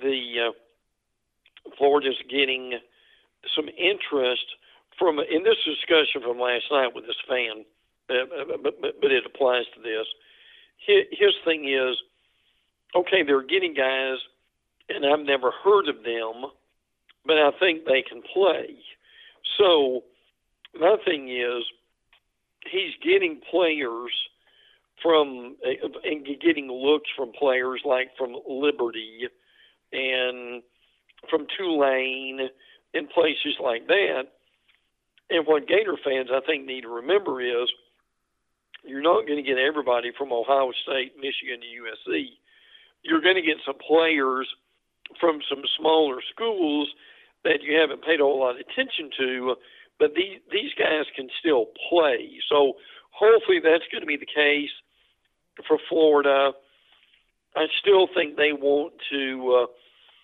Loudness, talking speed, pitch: -24 LUFS, 130 wpm, 145 Hz